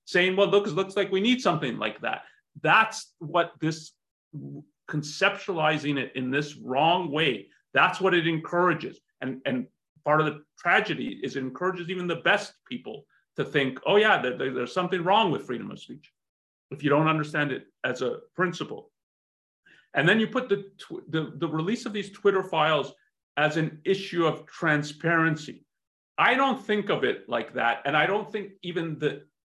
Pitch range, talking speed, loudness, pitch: 150-200 Hz, 180 wpm, -26 LUFS, 170 Hz